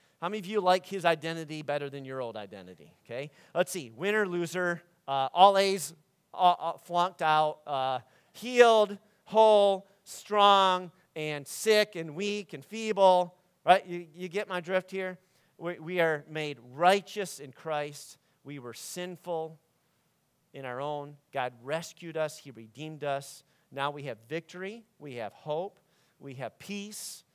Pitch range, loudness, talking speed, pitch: 145-190 Hz, -29 LUFS, 150 wpm, 170 Hz